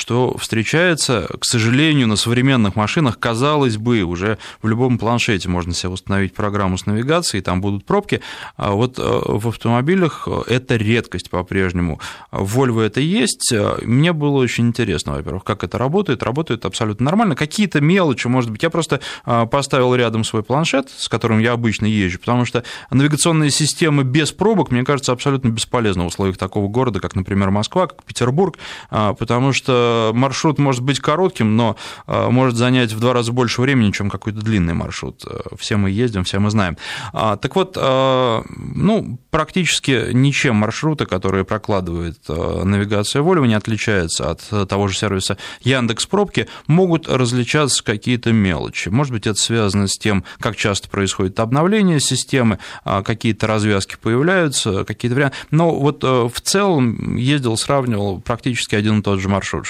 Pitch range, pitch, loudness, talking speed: 105-135 Hz, 115 Hz, -17 LUFS, 155 wpm